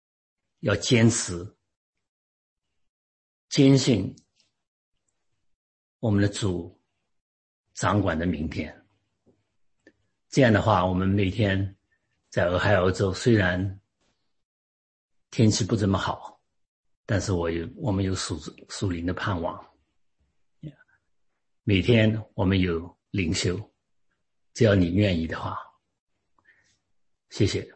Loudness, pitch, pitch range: -25 LUFS, 95 Hz, 85-105 Hz